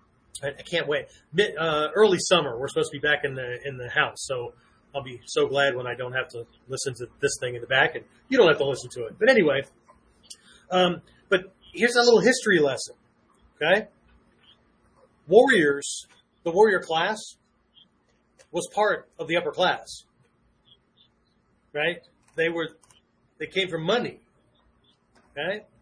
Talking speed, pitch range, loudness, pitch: 160 wpm, 130-190 Hz, -24 LUFS, 150 Hz